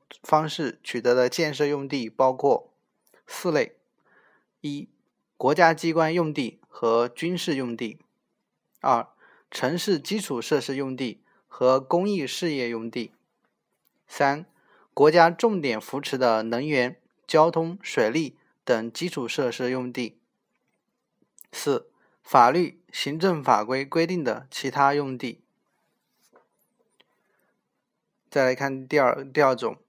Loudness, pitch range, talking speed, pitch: -24 LUFS, 125-165 Hz, 170 characters per minute, 140 Hz